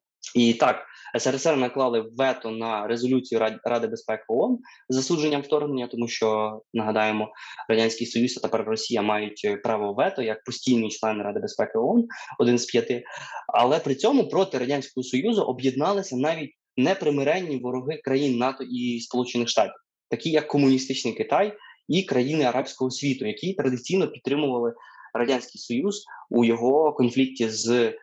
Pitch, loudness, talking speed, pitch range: 125 Hz, -25 LUFS, 140 wpm, 115-145 Hz